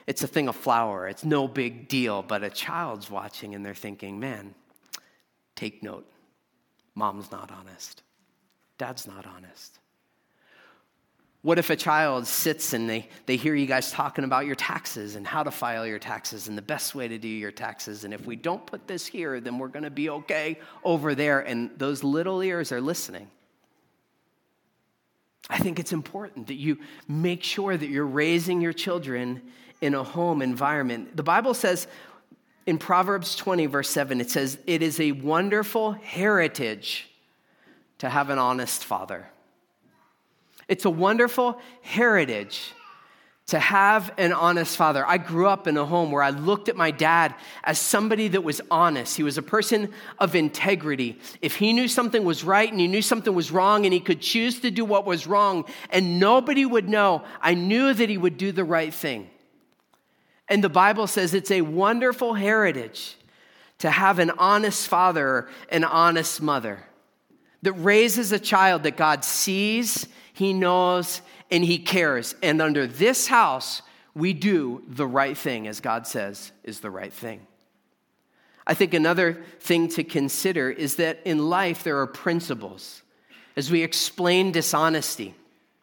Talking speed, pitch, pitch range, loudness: 165 wpm, 170 Hz, 140-195 Hz, -23 LUFS